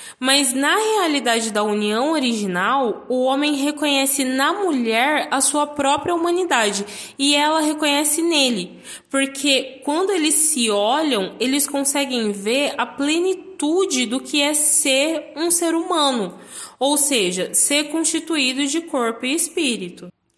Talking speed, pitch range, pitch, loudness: 130 wpm, 250-310 Hz, 280 Hz, -18 LUFS